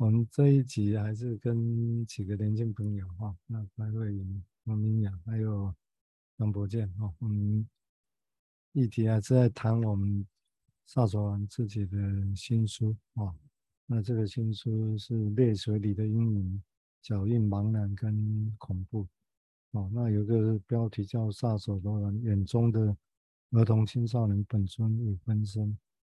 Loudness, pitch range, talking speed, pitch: -31 LUFS, 100-115 Hz, 210 characters per minute, 110 Hz